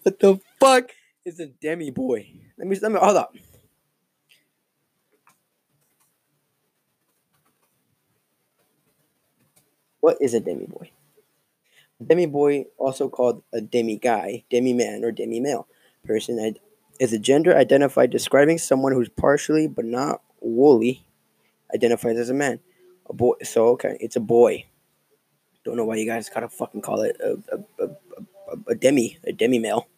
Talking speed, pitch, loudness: 145 wpm, 145 Hz, -21 LUFS